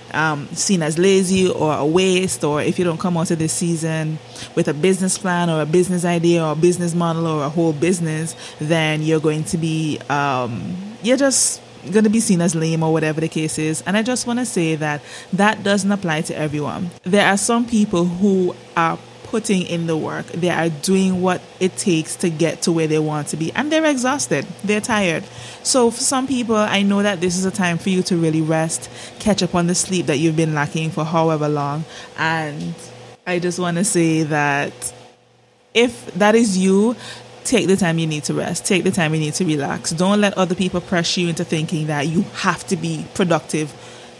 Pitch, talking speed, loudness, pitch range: 170 Hz, 215 wpm, -19 LUFS, 160-190 Hz